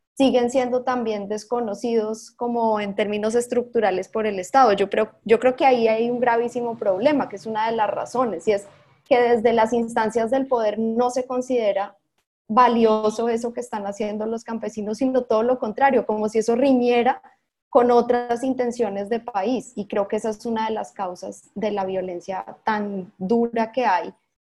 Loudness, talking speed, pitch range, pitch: -22 LUFS, 180 wpm, 210-245 Hz, 230 Hz